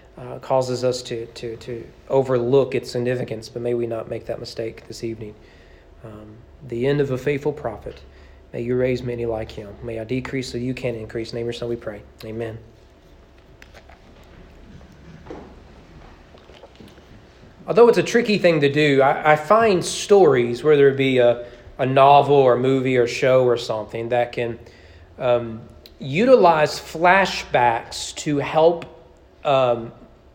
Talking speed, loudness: 155 wpm, -19 LUFS